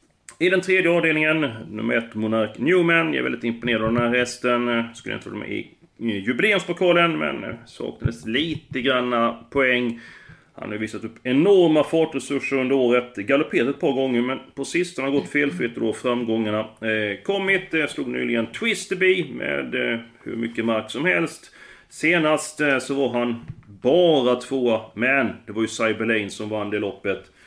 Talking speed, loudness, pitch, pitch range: 170 wpm, -22 LUFS, 125 Hz, 115-155 Hz